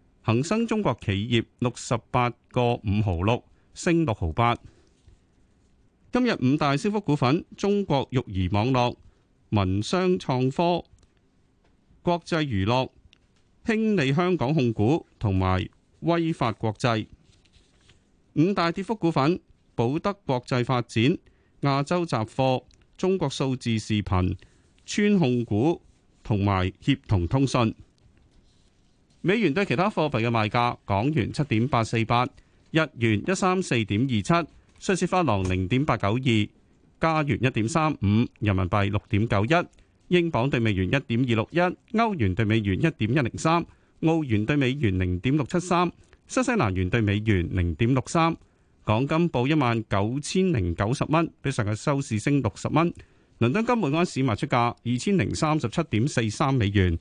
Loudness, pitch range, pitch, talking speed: -25 LUFS, 105-160 Hz, 125 Hz, 220 characters per minute